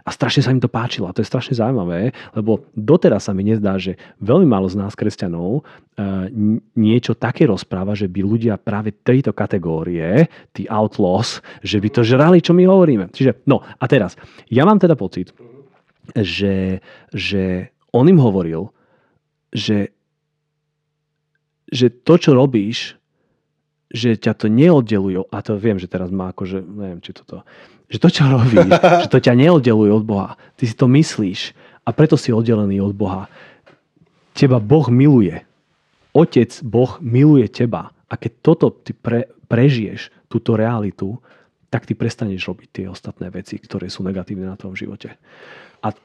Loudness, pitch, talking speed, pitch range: -16 LUFS, 115 Hz, 160 wpm, 100-140 Hz